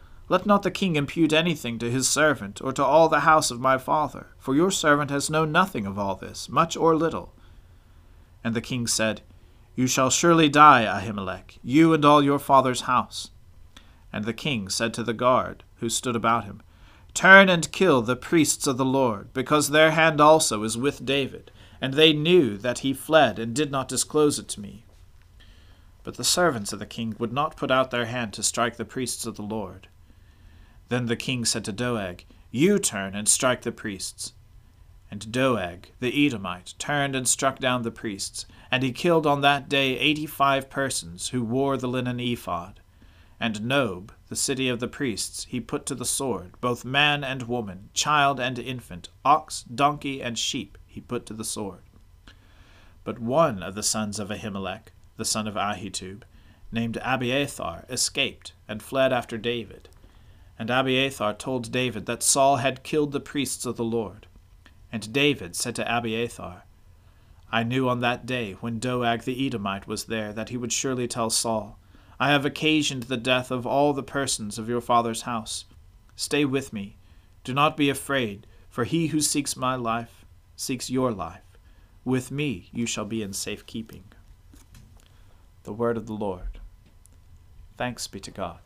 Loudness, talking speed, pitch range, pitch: -24 LUFS, 180 wpm, 100-135 Hz, 115 Hz